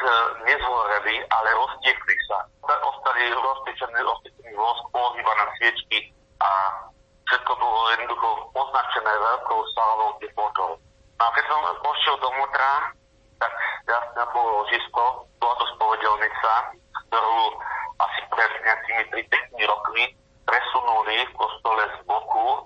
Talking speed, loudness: 110 wpm, -23 LUFS